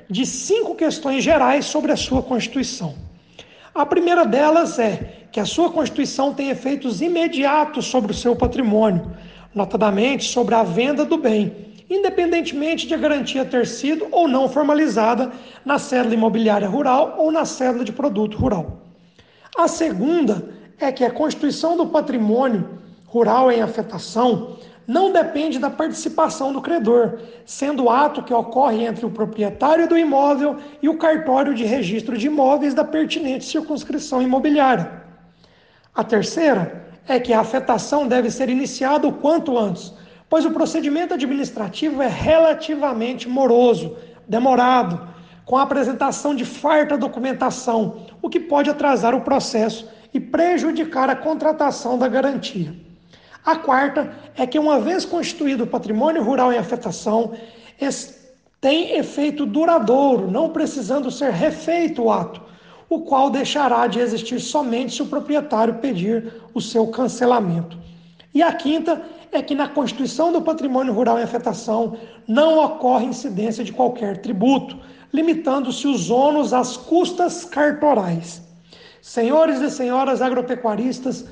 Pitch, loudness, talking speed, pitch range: 260 Hz, -19 LUFS, 135 wpm, 230-300 Hz